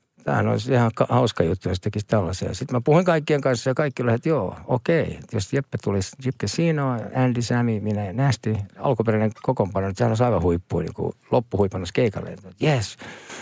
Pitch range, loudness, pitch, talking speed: 100-130 Hz, -23 LUFS, 115 Hz, 175 wpm